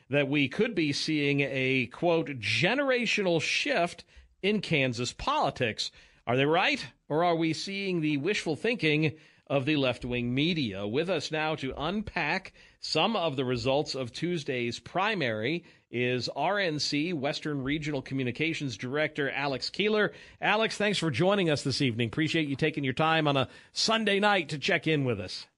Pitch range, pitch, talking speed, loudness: 135-170 Hz, 155 Hz, 160 wpm, -28 LUFS